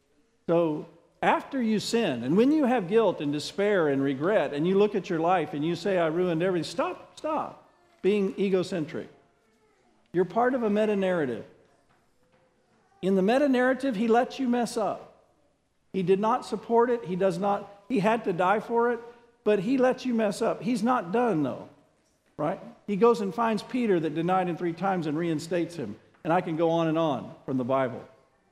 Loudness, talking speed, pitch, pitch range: -27 LUFS, 195 wpm, 200 Hz, 170-235 Hz